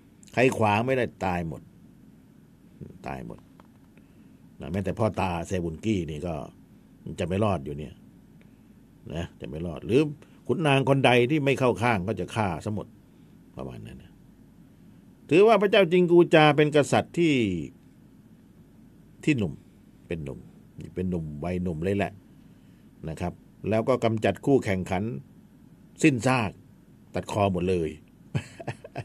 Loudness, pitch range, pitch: -25 LUFS, 90-140 Hz, 110 Hz